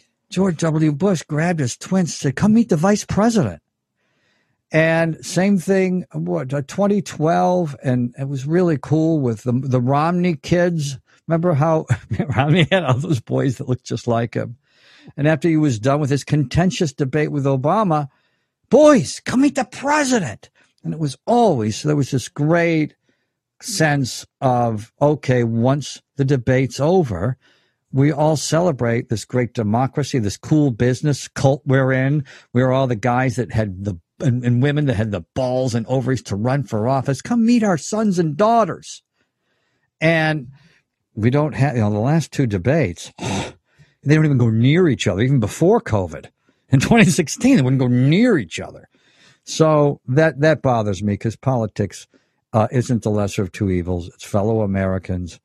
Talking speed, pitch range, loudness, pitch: 165 wpm, 125-160 Hz, -18 LUFS, 140 Hz